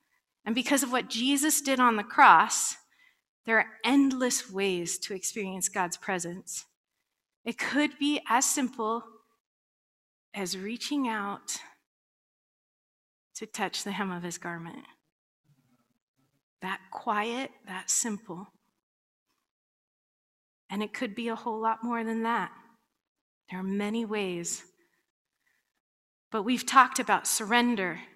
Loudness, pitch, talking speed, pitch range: -28 LUFS, 225 Hz, 115 wpm, 190-245 Hz